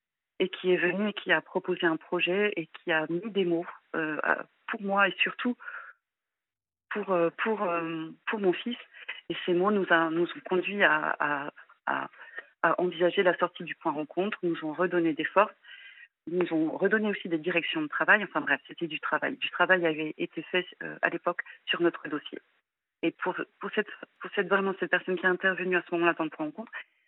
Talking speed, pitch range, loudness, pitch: 205 wpm, 170-195 Hz, -29 LUFS, 180 Hz